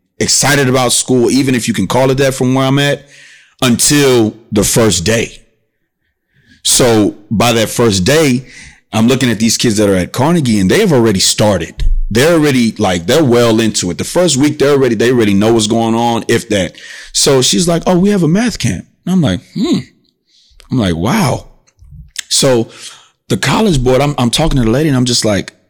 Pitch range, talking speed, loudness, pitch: 115-140 Hz, 205 wpm, -11 LUFS, 125 Hz